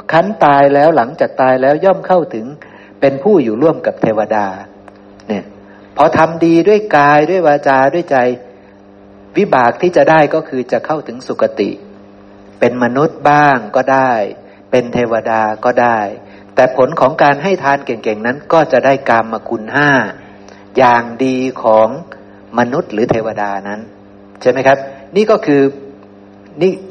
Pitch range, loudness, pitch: 100-145 Hz, -12 LUFS, 125 Hz